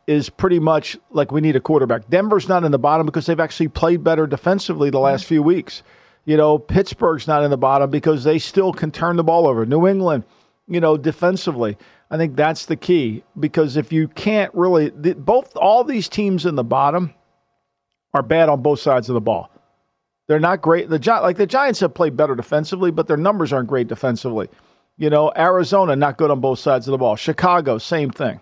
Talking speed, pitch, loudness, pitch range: 215 wpm, 160 Hz, -18 LUFS, 145-180 Hz